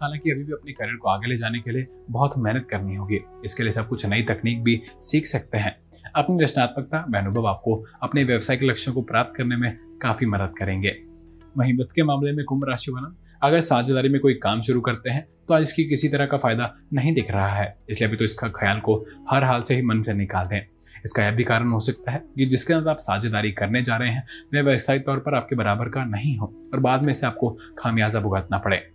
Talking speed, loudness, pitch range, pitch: 235 wpm, -23 LUFS, 105-135 Hz, 120 Hz